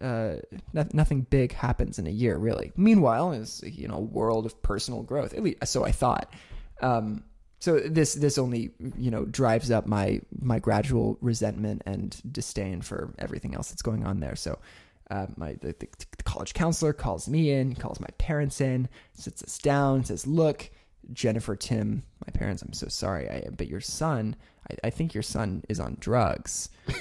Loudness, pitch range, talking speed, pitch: -28 LUFS, 110-145 Hz, 185 wpm, 120 Hz